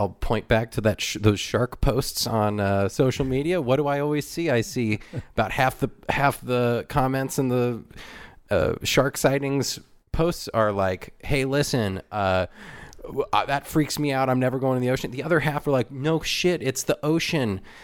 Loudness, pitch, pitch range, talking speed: -24 LUFS, 130 Hz, 110-145 Hz, 190 wpm